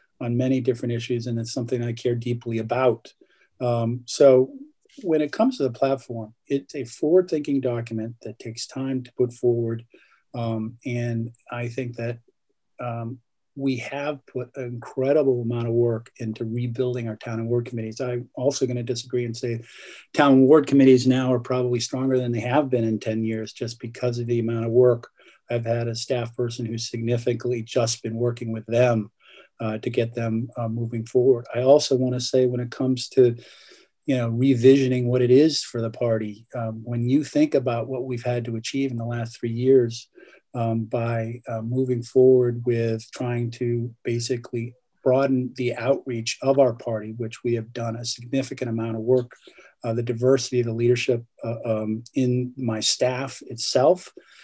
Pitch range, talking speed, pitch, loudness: 115-130 Hz, 185 wpm, 120 Hz, -24 LUFS